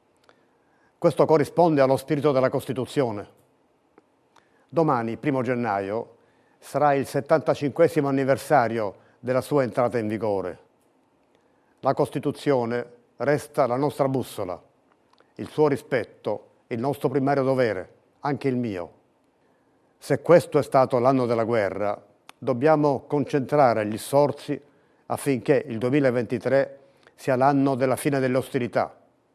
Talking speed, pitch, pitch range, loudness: 110 wpm, 135 Hz, 125-145 Hz, -24 LUFS